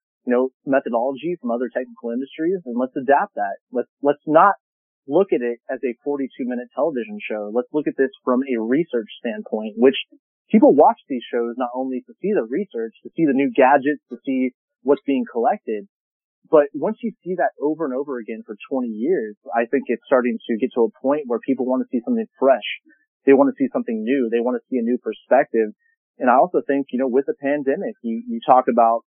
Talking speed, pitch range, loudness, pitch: 215 wpm, 120-165 Hz, -21 LUFS, 130 Hz